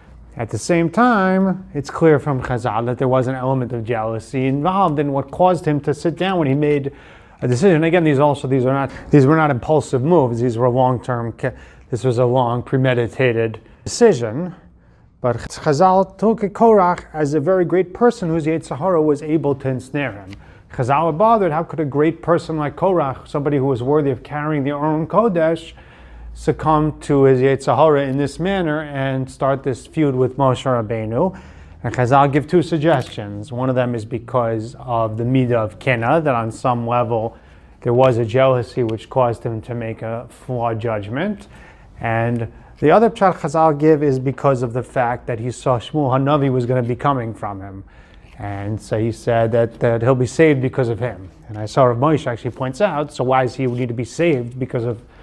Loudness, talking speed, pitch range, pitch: -18 LUFS, 195 wpm, 120-155 Hz, 130 Hz